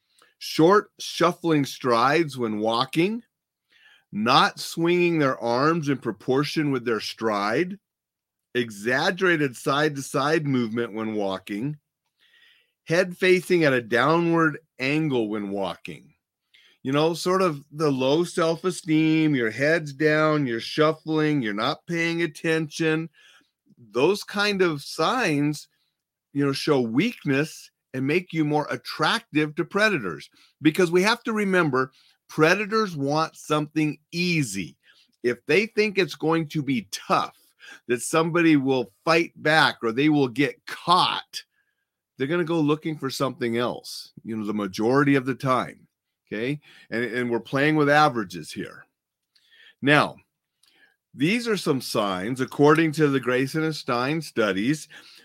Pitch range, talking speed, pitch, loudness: 130-170 Hz, 135 wpm, 155 Hz, -23 LUFS